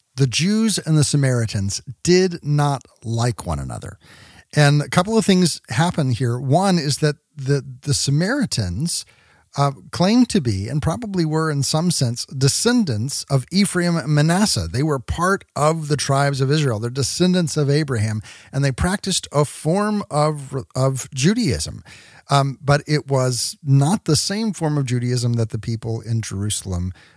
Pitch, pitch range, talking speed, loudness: 140 Hz, 125-165 Hz, 160 wpm, -20 LUFS